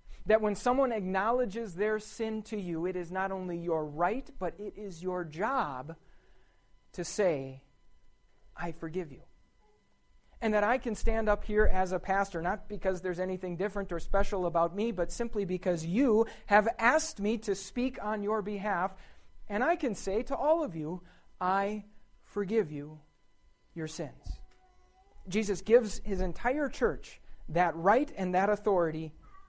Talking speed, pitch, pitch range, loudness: 160 wpm, 200 Hz, 175-220 Hz, -32 LUFS